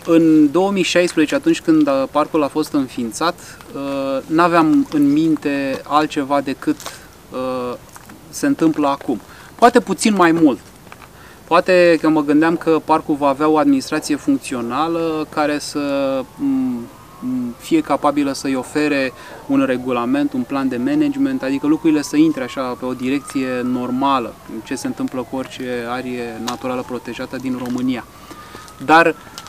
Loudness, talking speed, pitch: -18 LUFS, 130 wpm, 155 Hz